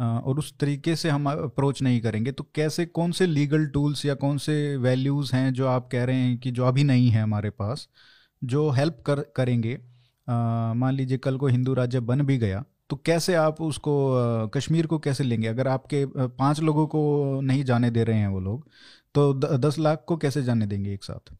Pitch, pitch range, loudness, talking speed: 135 Hz, 125-150 Hz, -25 LUFS, 210 wpm